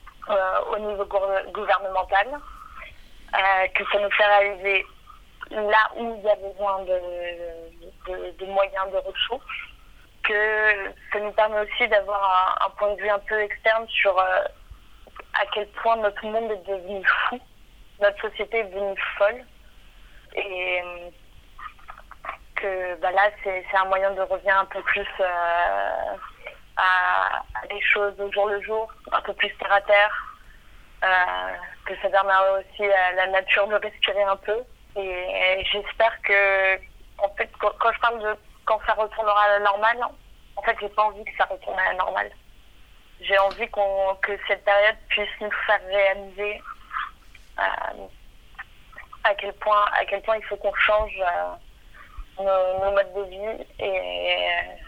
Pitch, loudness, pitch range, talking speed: 200 Hz, -23 LUFS, 190-210 Hz, 155 wpm